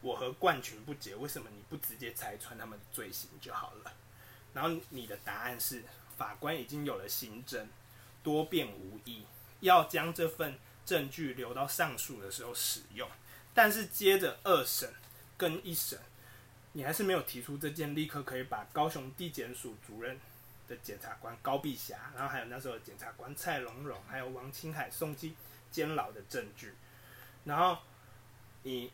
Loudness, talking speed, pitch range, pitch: -36 LUFS, 255 characters per minute, 120-155 Hz, 130 Hz